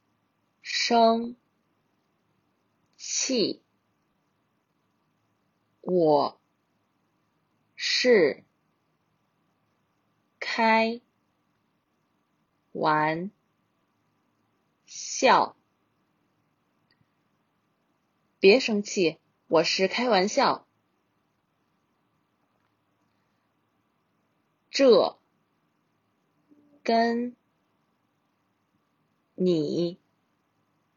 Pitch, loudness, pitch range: 225 Hz, -24 LUFS, 170-255 Hz